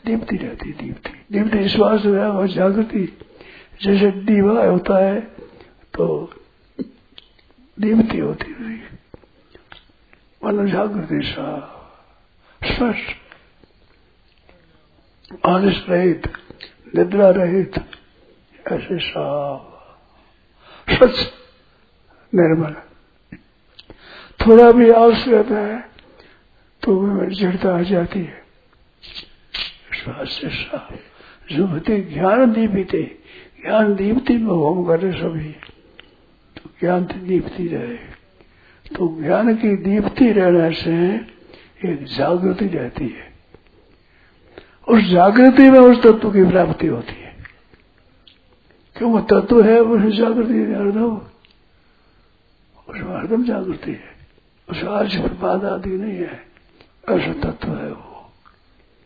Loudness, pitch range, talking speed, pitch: -16 LUFS, 170-225 Hz, 95 wpm, 195 Hz